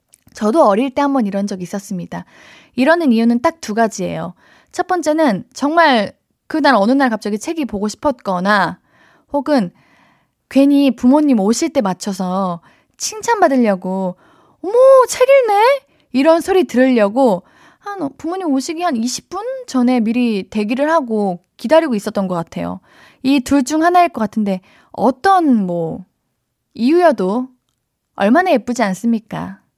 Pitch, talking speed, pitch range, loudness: 260 Hz, 280 characters per minute, 210-320 Hz, -15 LUFS